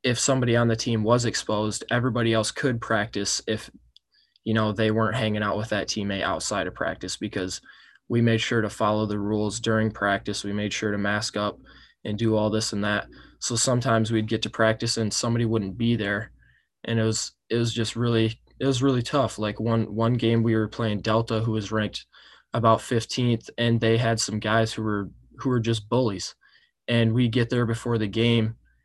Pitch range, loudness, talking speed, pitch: 105-115 Hz, -25 LUFS, 205 wpm, 110 Hz